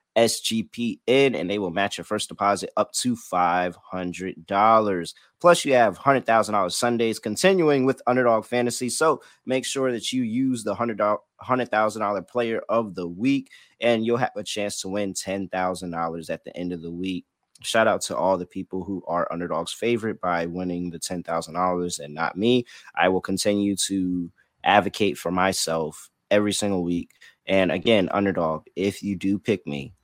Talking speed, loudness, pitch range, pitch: 165 wpm, -24 LUFS, 90-120 Hz, 100 Hz